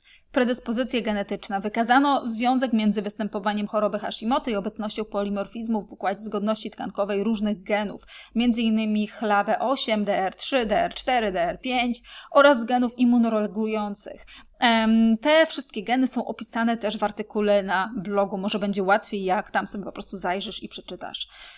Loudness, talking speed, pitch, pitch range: -24 LUFS, 130 wpm, 215 Hz, 205-240 Hz